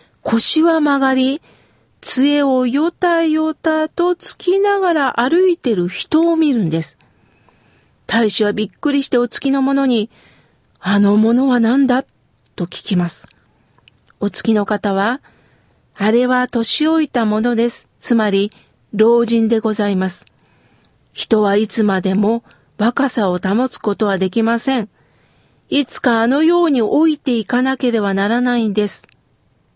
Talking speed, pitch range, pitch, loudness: 250 characters per minute, 205-275 Hz, 235 Hz, -16 LUFS